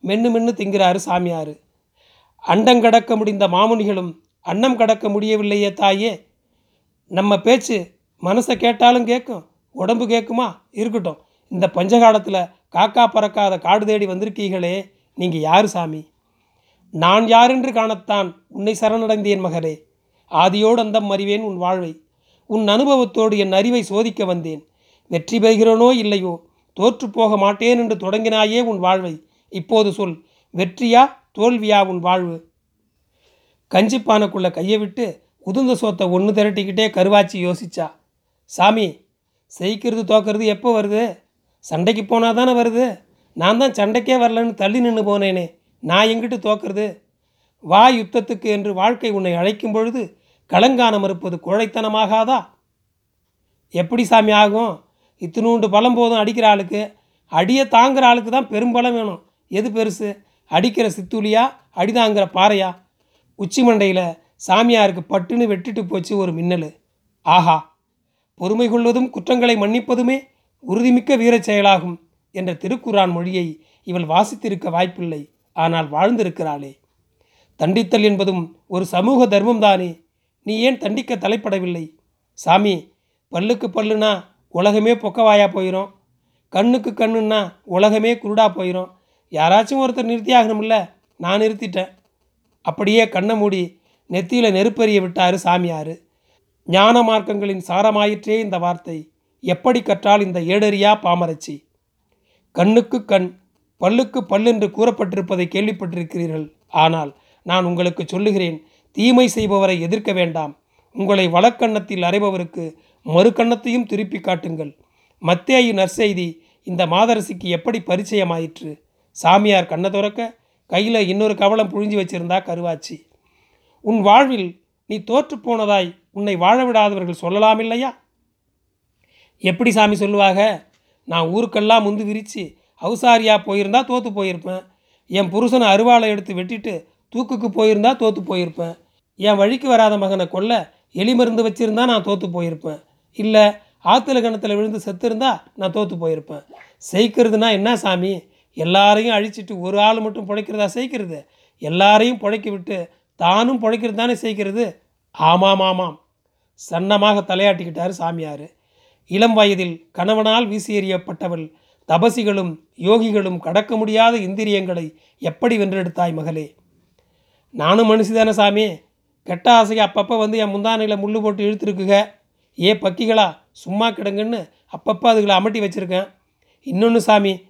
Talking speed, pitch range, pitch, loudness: 110 wpm, 180-225 Hz, 205 Hz, -17 LUFS